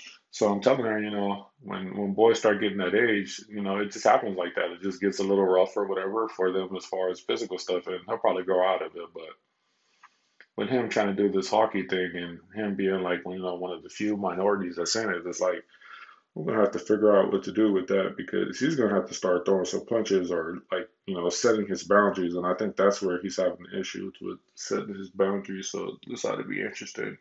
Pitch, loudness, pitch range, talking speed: 95 Hz, -27 LUFS, 95-105 Hz, 255 wpm